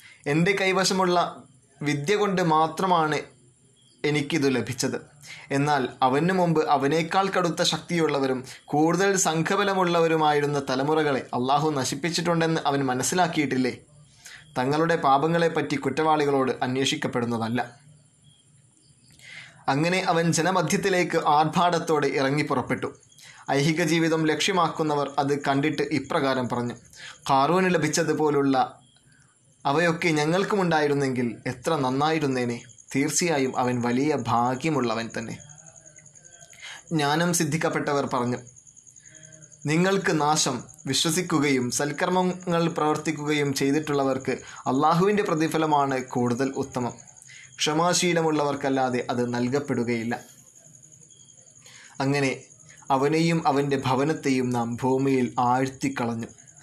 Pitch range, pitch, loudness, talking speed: 130-160 Hz, 145 Hz, -24 LUFS, 75 wpm